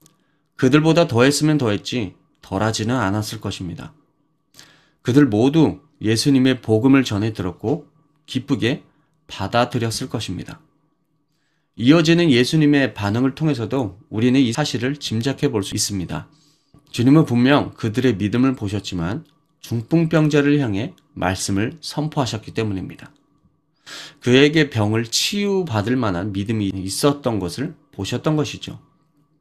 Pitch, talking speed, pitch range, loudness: 130 Hz, 290 characters per minute, 110-150 Hz, -19 LUFS